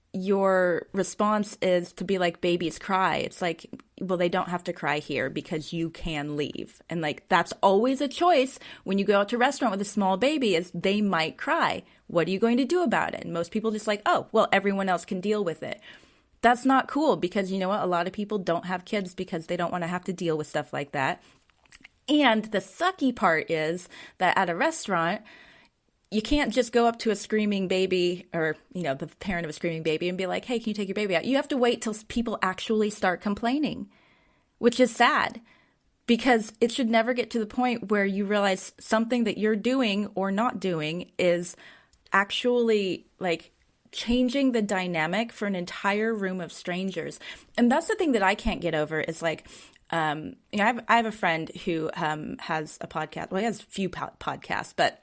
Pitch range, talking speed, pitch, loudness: 175-230 Hz, 220 wpm, 195 Hz, -26 LUFS